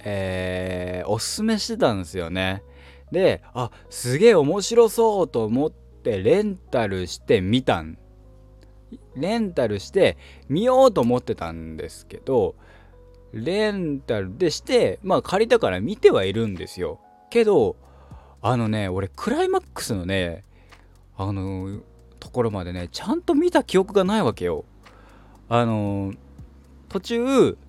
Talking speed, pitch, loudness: 260 characters per minute, 100 Hz, -22 LUFS